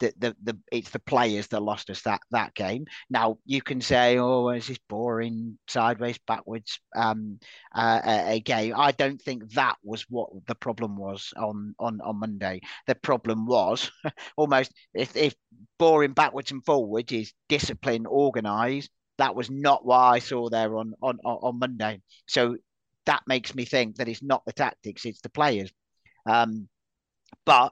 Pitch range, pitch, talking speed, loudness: 110-130 Hz, 115 Hz, 170 wpm, -26 LUFS